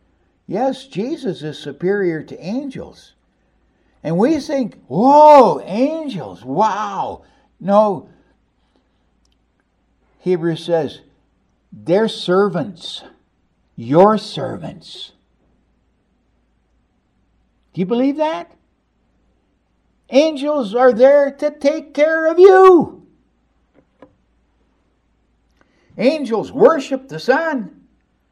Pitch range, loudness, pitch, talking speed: 175-285 Hz, -15 LUFS, 235 Hz, 75 wpm